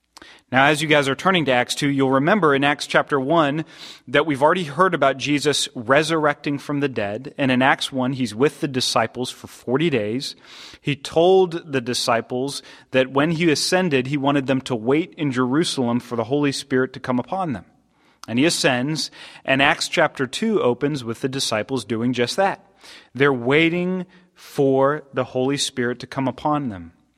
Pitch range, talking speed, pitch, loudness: 130-150 Hz, 185 wpm, 140 Hz, -20 LUFS